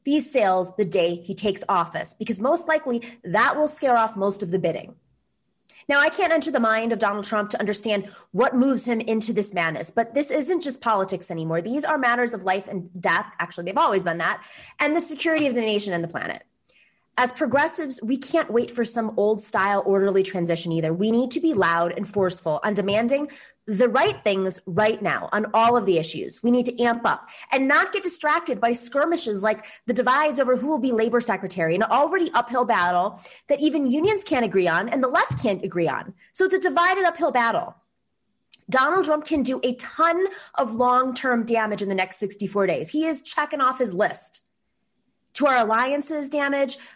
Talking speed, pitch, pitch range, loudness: 205 wpm, 235 Hz, 195-285 Hz, -22 LUFS